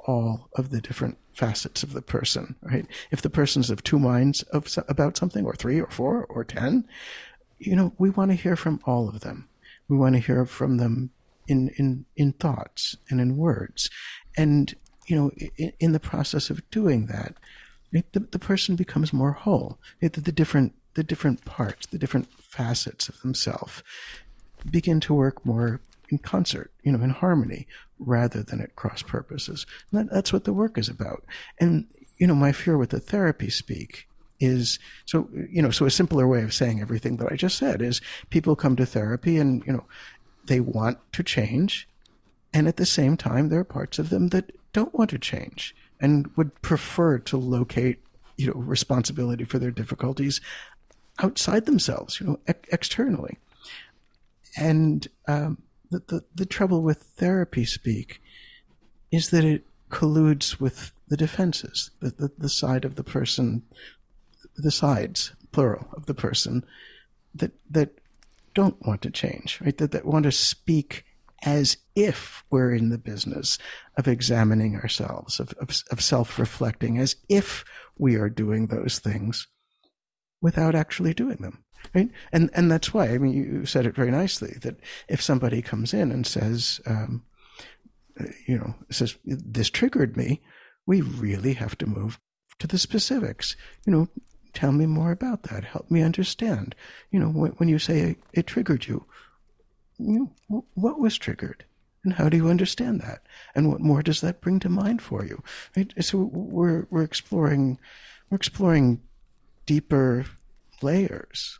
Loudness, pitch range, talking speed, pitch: -25 LUFS, 125-170 Hz, 170 wpm, 145 Hz